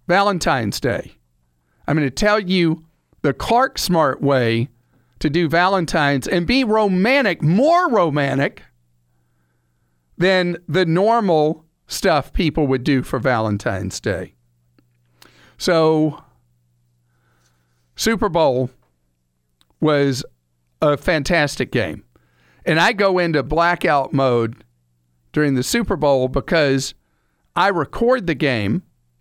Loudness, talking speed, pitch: -18 LUFS, 105 wpm, 140 Hz